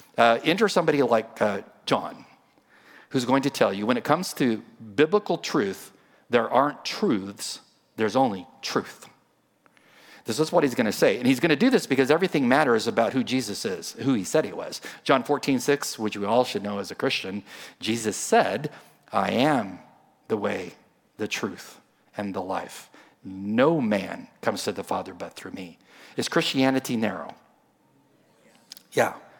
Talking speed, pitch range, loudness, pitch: 170 wpm, 110-145 Hz, -25 LUFS, 130 Hz